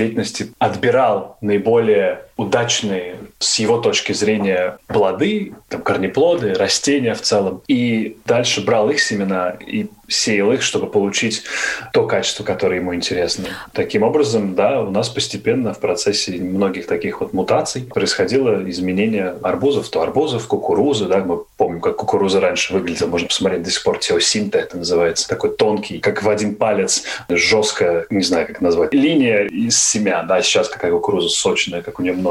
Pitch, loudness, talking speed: 120 Hz, -17 LUFS, 160 wpm